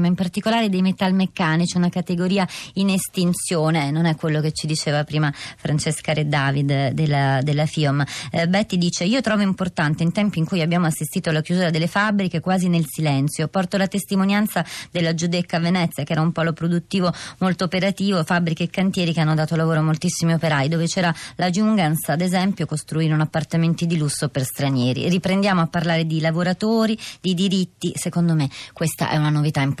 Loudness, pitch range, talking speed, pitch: -21 LUFS, 155-185 Hz, 180 wpm, 170 Hz